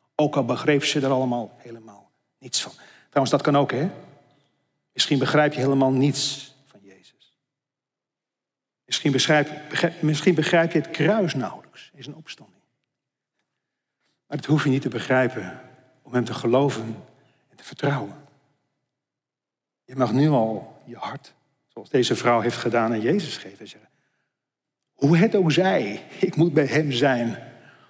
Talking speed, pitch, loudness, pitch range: 155 wpm, 140 Hz, -22 LUFS, 125-150 Hz